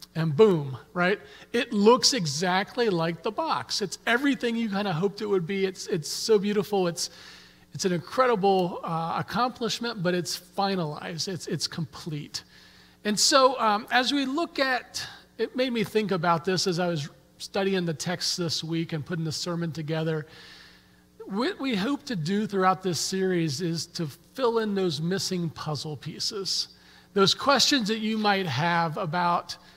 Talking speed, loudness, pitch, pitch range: 165 wpm, -26 LUFS, 185 Hz, 165-215 Hz